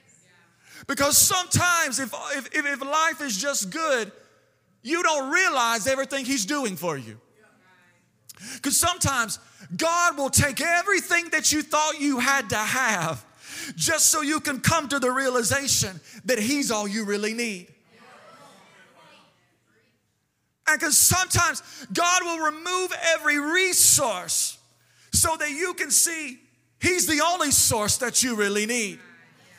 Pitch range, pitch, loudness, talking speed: 235-325 Hz, 280 Hz, -22 LUFS, 130 wpm